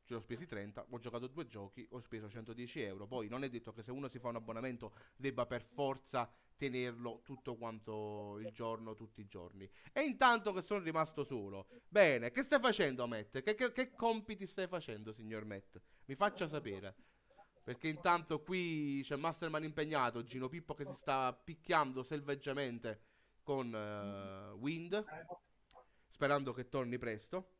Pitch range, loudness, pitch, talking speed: 115-160 Hz, -40 LUFS, 130 Hz, 165 wpm